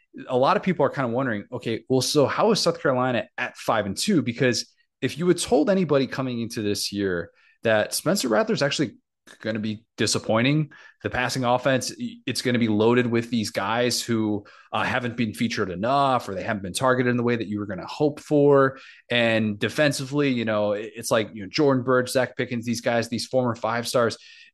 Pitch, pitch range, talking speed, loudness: 125 Hz, 115-140 Hz, 215 wpm, -24 LUFS